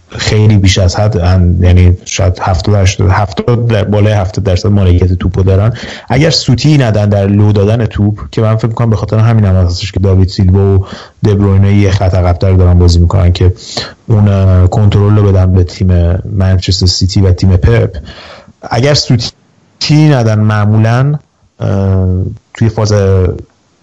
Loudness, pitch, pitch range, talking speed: -9 LUFS, 100 Hz, 95-110 Hz, 150 wpm